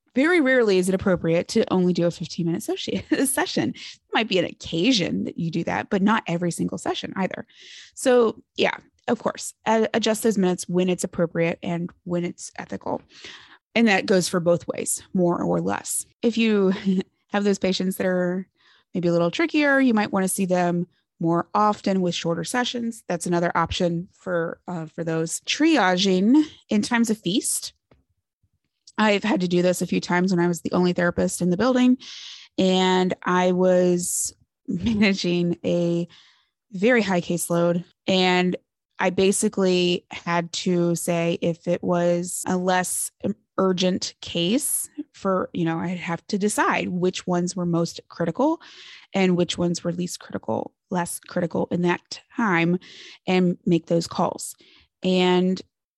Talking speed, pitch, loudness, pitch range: 160 wpm, 180 Hz, -23 LUFS, 175-210 Hz